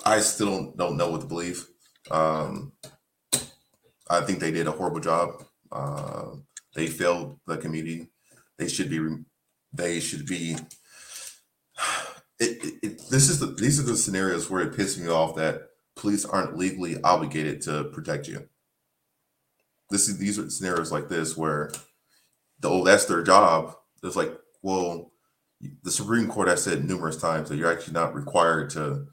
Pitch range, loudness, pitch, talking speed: 80-95 Hz, -26 LUFS, 85 Hz, 160 wpm